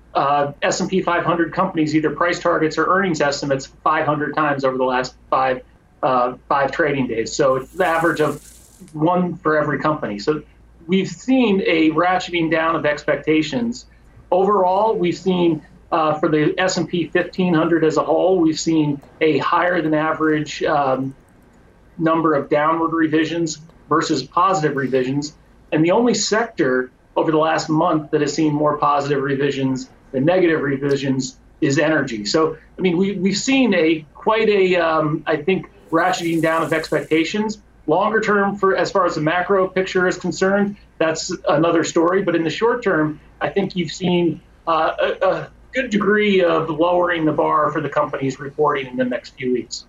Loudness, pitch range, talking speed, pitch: -19 LUFS, 150-180 Hz, 165 wpm, 160 Hz